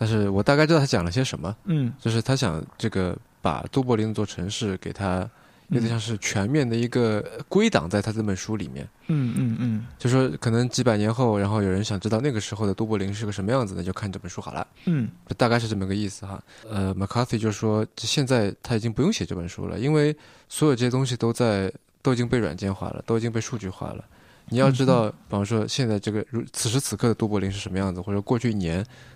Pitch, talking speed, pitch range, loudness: 110 Hz, 370 characters per minute, 100-125 Hz, -25 LUFS